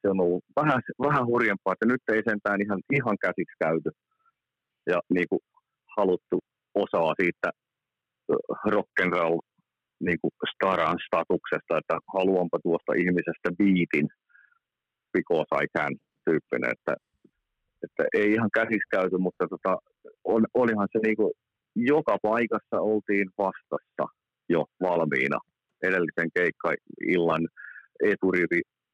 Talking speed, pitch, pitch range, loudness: 115 wpm, 100 Hz, 90-115 Hz, -27 LUFS